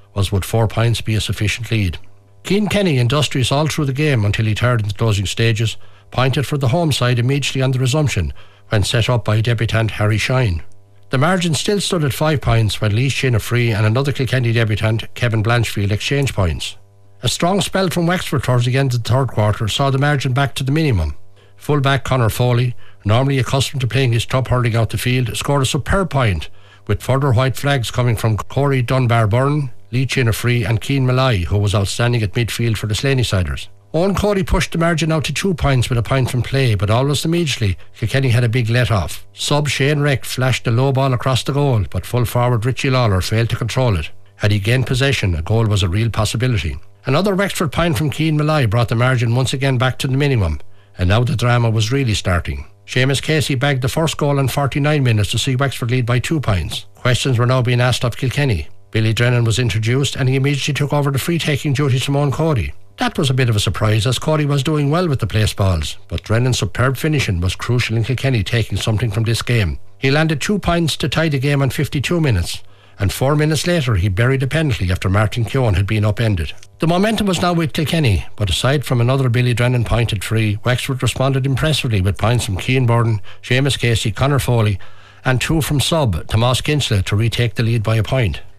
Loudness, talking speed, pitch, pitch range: -17 LUFS, 215 wpm, 125 Hz, 110-140 Hz